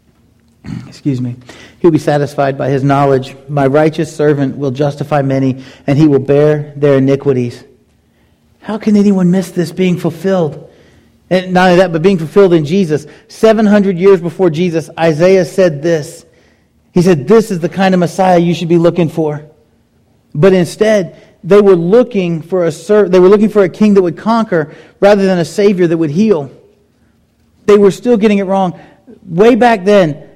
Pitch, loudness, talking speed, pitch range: 175 Hz, -11 LUFS, 180 wpm, 150-195 Hz